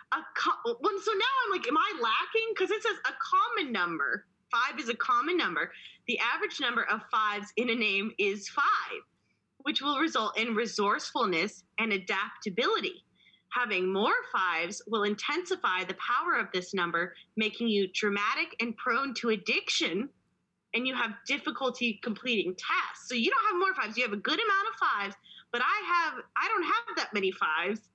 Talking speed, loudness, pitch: 180 wpm, -29 LUFS, 235 Hz